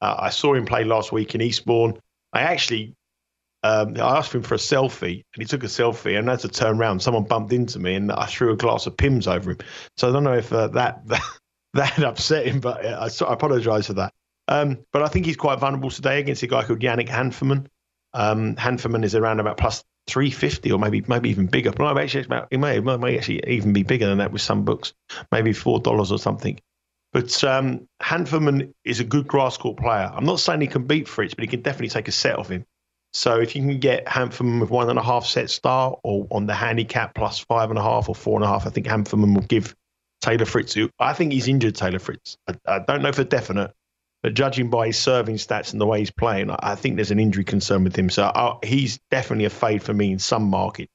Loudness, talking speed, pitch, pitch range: -22 LUFS, 245 wpm, 115 Hz, 105-130 Hz